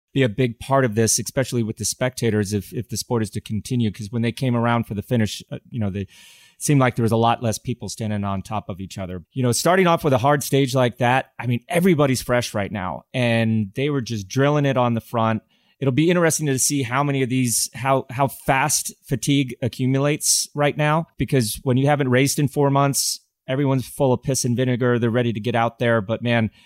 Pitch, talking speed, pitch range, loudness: 125 Hz, 235 wpm, 110-135 Hz, -21 LUFS